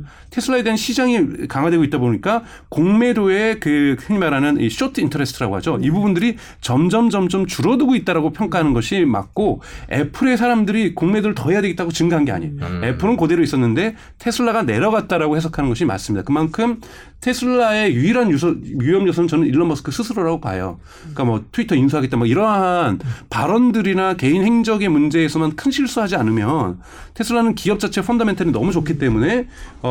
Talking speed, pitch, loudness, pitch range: 430 characters per minute, 175 Hz, -18 LUFS, 145-225 Hz